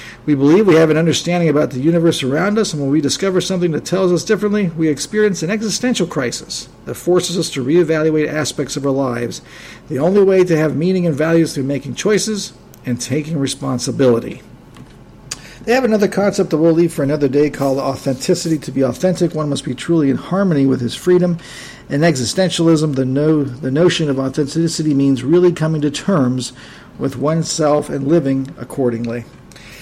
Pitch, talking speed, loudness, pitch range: 155 Hz, 185 wpm, -16 LUFS, 135-175 Hz